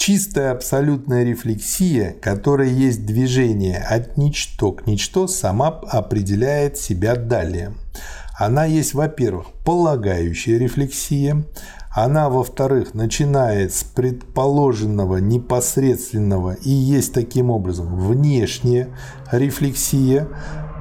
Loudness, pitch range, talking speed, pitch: -19 LUFS, 105-140 Hz, 90 wpm, 125 Hz